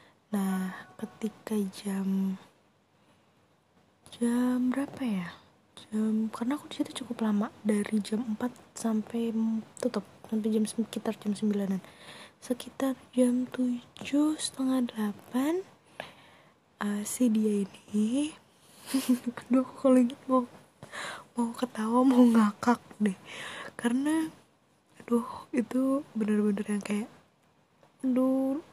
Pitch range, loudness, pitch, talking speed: 215-255 Hz, -30 LUFS, 235 Hz, 100 wpm